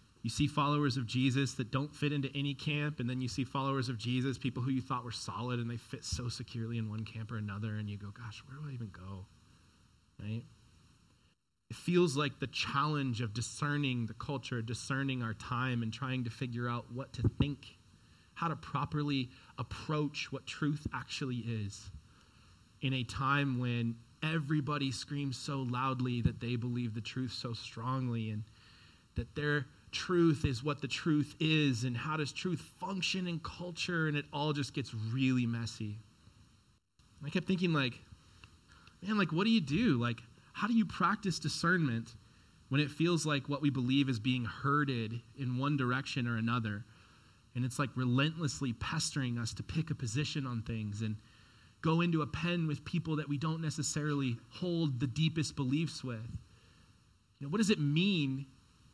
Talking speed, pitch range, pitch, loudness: 180 wpm, 115-145 Hz, 130 Hz, -35 LUFS